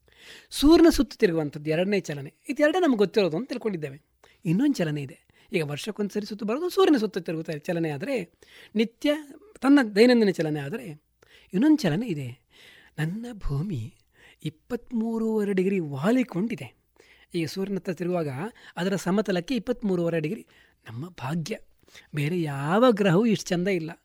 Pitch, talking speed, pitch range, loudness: 195 Hz, 125 wpm, 160-230 Hz, -25 LUFS